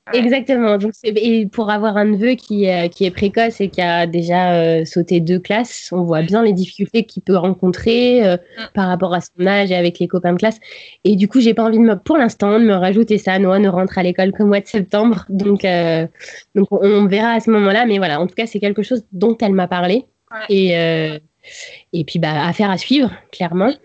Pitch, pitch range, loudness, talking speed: 200 Hz, 180-225 Hz, -15 LUFS, 230 wpm